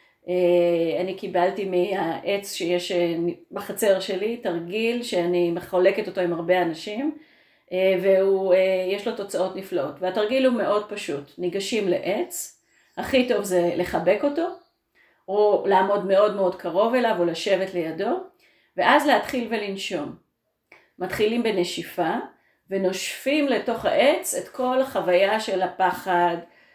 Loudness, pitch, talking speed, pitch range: -23 LUFS, 195 Hz, 110 wpm, 180-225 Hz